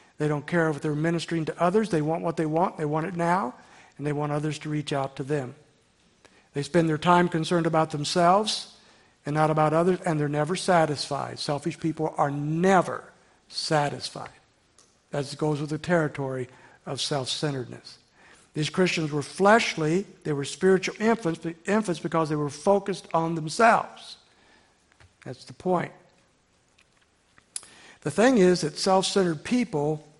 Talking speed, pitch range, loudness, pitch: 155 wpm, 150-175 Hz, -25 LUFS, 160 Hz